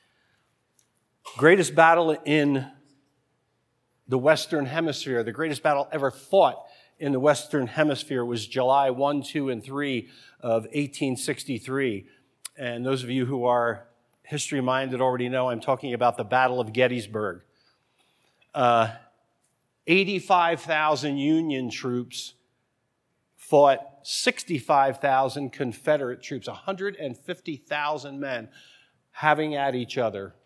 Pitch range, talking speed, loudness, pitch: 125-150 Hz, 105 wpm, -25 LUFS, 135 Hz